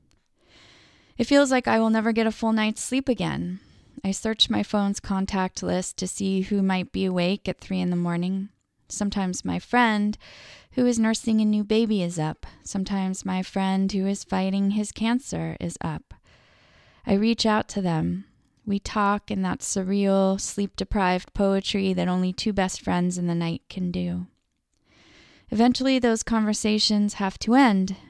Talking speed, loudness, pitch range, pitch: 170 wpm, -24 LUFS, 185-220 Hz, 195 Hz